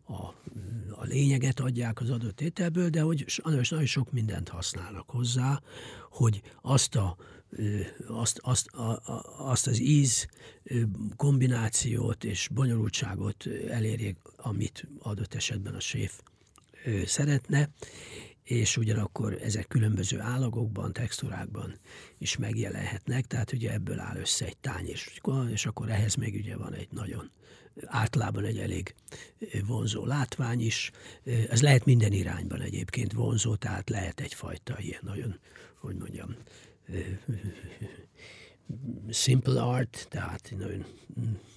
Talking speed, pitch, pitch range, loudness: 115 wpm, 115 Hz, 105-130 Hz, -30 LUFS